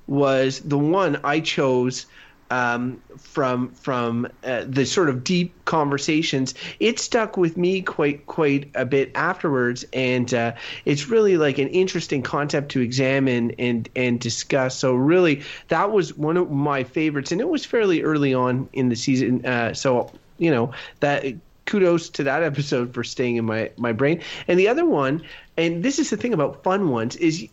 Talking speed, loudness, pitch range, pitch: 175 wpm, -22 LUFS, 125-165 Hz, 140 Hz